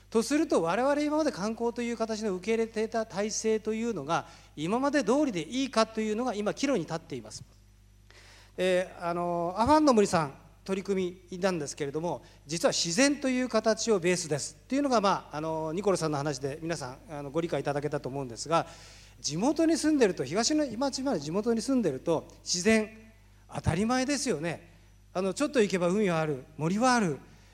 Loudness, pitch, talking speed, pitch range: -29 LUFS, 185 Hz, 390 characters per minute, 145-230 Hz